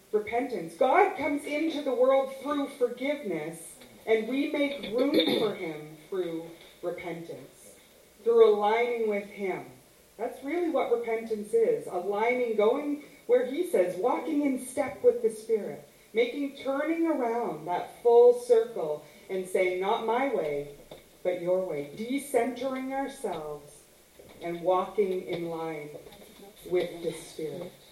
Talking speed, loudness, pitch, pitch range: 125 wpm, -28 LUFS, 235 Hz, 185-285 Hz